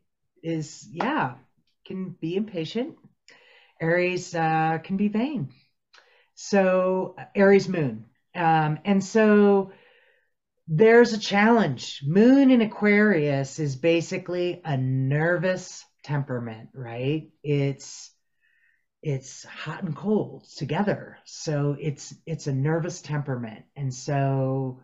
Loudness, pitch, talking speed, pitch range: -24 LUFS, 165 Hz, 100 wpm, 145-200 Hz